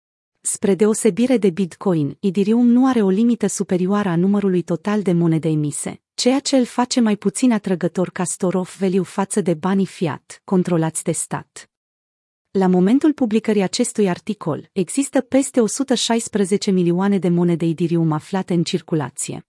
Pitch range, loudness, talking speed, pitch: 175-225 Hz, -19 LUFS, 145 wpm, 195 Hz